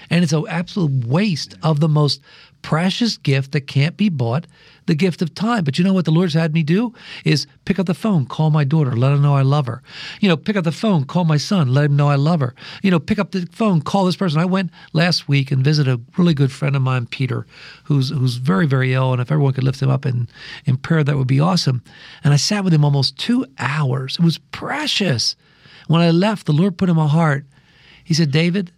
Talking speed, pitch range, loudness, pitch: 250 wpm, 140-180 Hz, -18 LUFS, 155 Hz